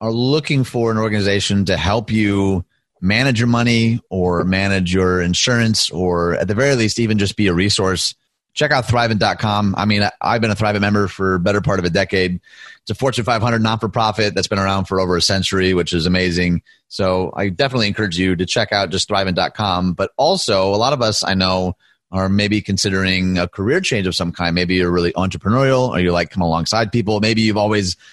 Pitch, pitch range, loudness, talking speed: 100 Hz, 90-110 Hz, -17 LUFS, 205 wpm